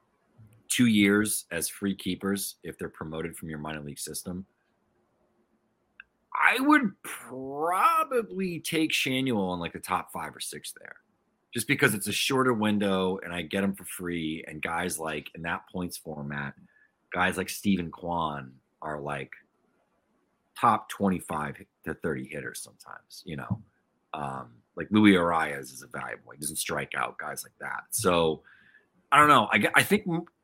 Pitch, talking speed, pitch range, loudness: 95 Hz, 160 wpm, 80-110 Hz, -27 LUFS